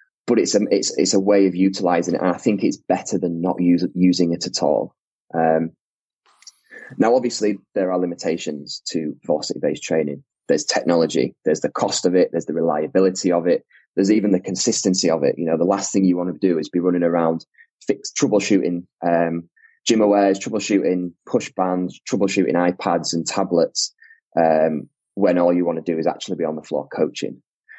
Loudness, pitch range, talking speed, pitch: -20 LUFS, 85-95 Hz, 190 wpm, 90 Hz